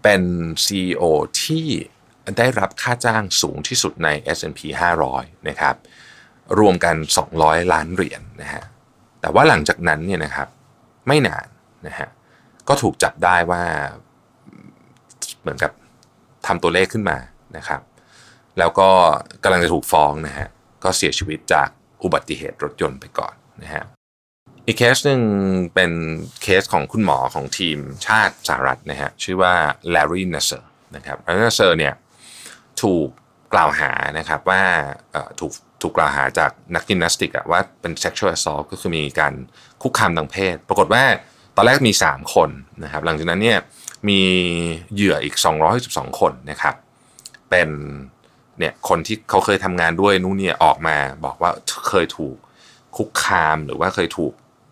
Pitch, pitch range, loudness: 90 Hz, 80-95 Hz, -18 LUFS